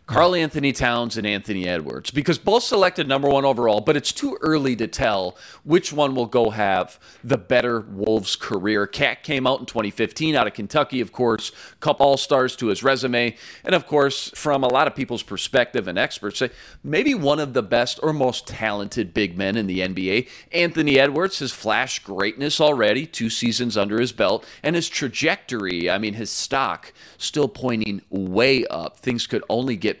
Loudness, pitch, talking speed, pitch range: -21 LUFS, 125 Hz, 190 wpm, 110-145 Hz